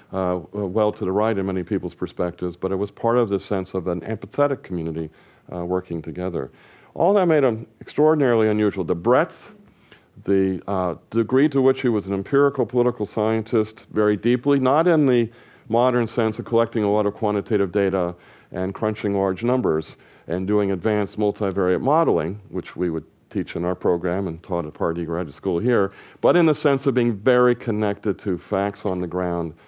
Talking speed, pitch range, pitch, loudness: 190 wpm, 90-120 Hz, 105 Hz, -22 LUFS